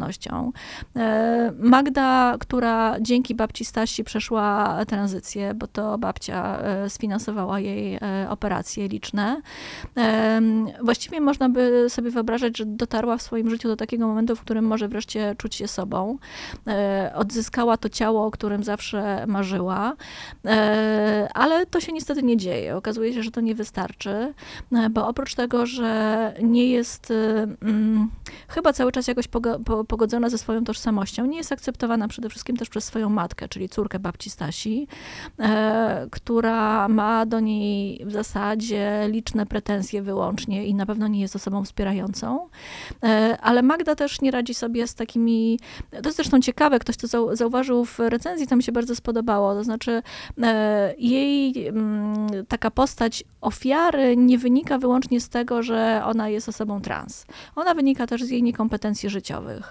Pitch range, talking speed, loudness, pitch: 210-245 Hz, 150 wpm, -23 LUFS, 225 Hz